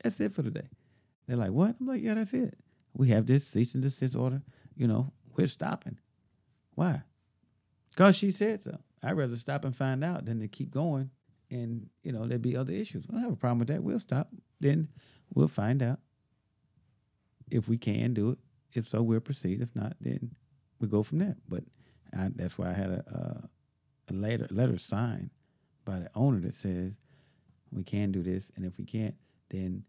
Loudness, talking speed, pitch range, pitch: -32 LUFS, 205 wpm, 110-145 Hz, 130 Hz